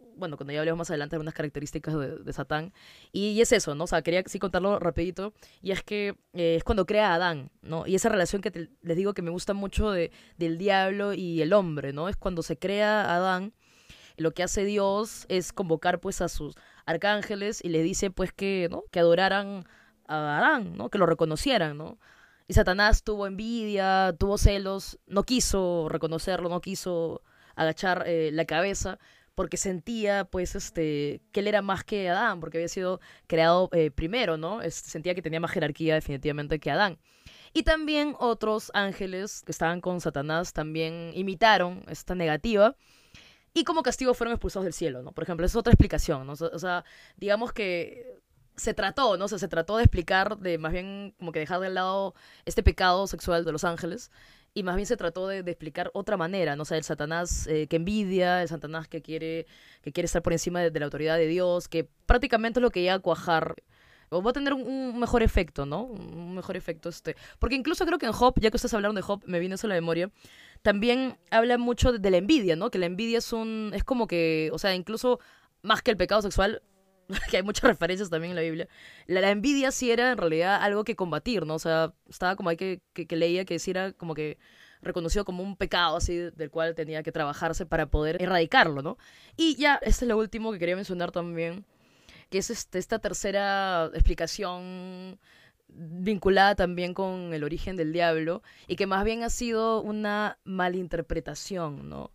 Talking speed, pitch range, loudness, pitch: 205 wpm, 165-205 Hz, -27 LUFS, 180 Hz